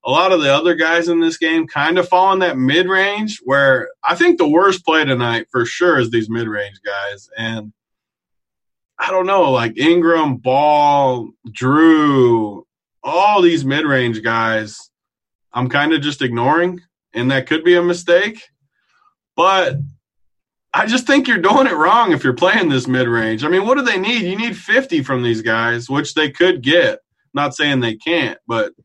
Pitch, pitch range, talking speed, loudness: 150 Hz, 125-185 Hz, 185 wpm, -15 LUFS